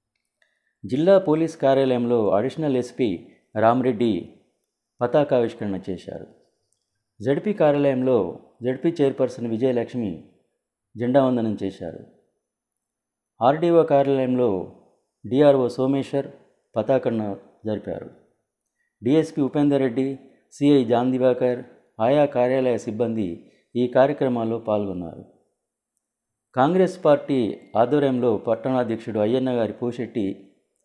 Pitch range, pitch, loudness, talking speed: 115-140 Hz, 125 Hz, -22 LUFS, 80 wpm